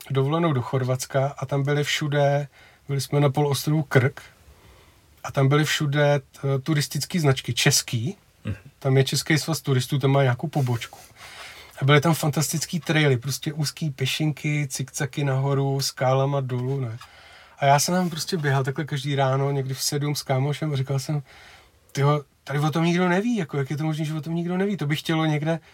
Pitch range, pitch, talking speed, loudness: 135-155 Hz, 145 Hz, 185 wpm, -23 LUFS